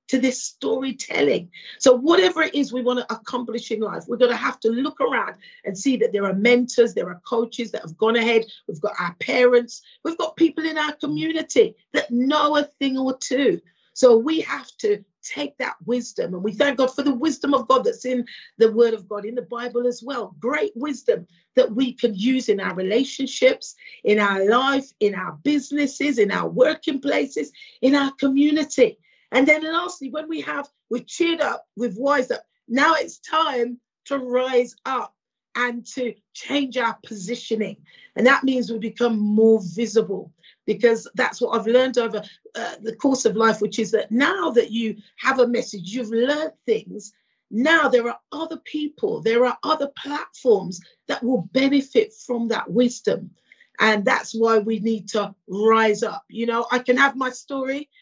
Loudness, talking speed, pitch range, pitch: -21 LUFS, 185 wpm, 225-285 Hz, 250 Hz